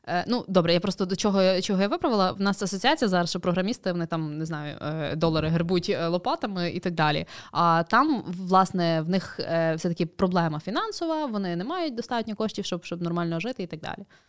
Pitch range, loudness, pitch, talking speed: 170-200 Hz, -26 LUFS, 185 Hz, 195 wpm